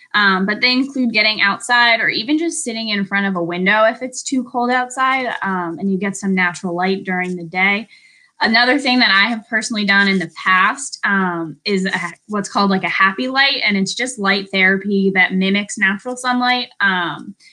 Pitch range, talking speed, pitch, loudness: 190-250 Hz, 200 wpm, 205 Hz, -16 LUFS